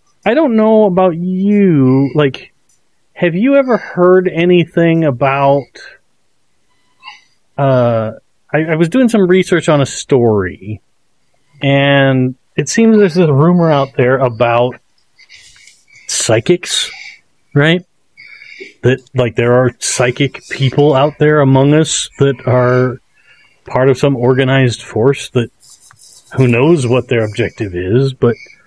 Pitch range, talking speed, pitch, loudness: 125-170 Hz, 120 wpm, 140 Hz, -12 LUFS